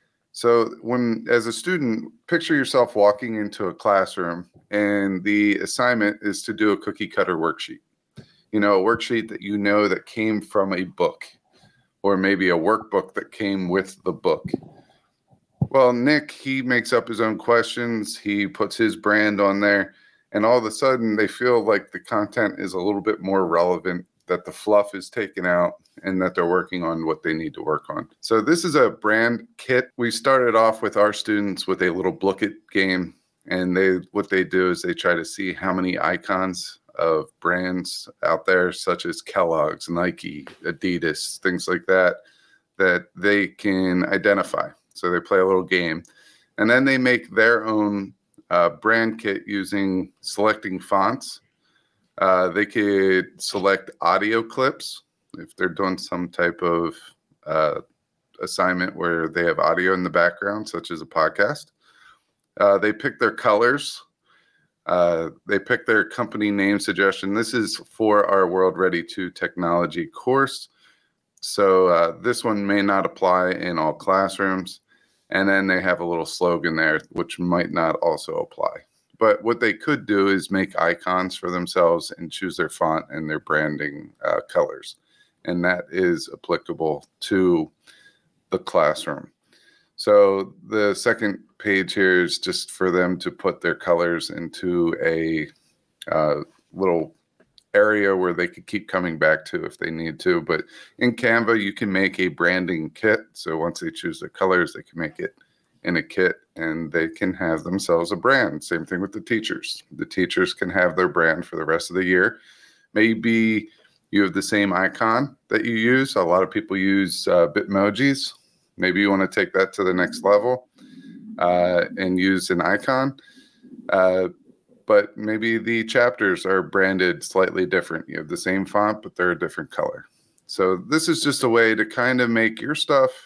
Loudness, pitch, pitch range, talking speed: -21 LUFS, 100 Hz, 90-115 Hz, 175 wpm